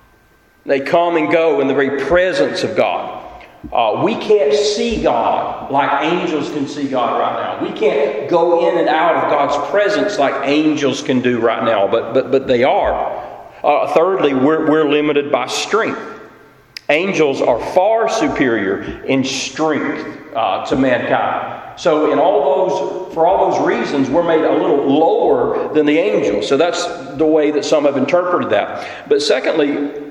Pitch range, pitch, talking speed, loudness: 140-170 Hz, 150 Hz, 170 wpm, -15 LUFS